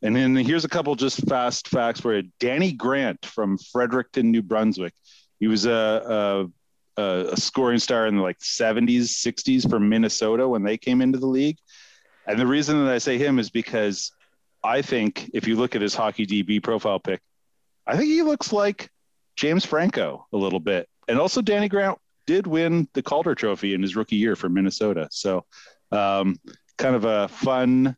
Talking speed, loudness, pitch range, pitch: 185 wpm, -23 LUFS, 105-135 Hz, 120 Hz